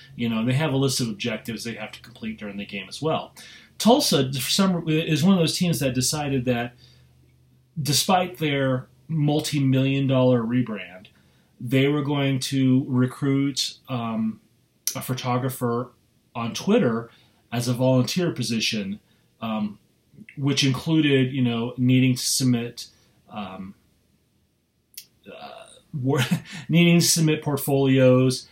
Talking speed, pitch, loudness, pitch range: 125 wpm, 130 Hz, -23 LUFS, 115-140 Hz